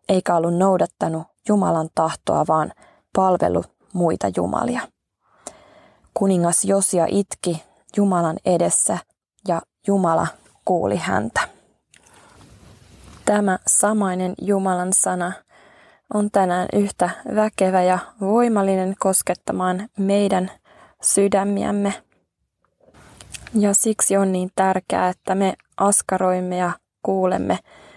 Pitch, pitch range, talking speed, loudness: 190 Hz, 180-200 Hz, 90 wpm, -20 LUFS